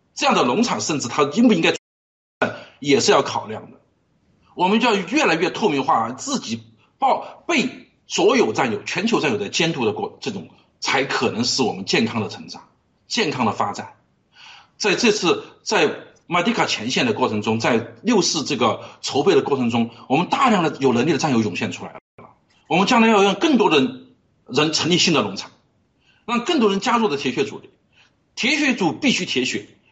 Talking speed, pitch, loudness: 275 characters per minute, 180 Hz, -19 LUFS